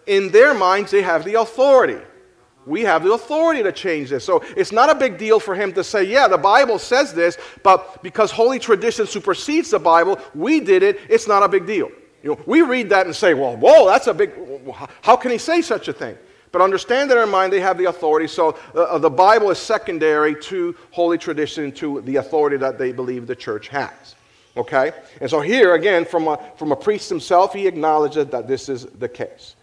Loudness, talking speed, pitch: -17 LUFS, 220 wpm, 195 Hz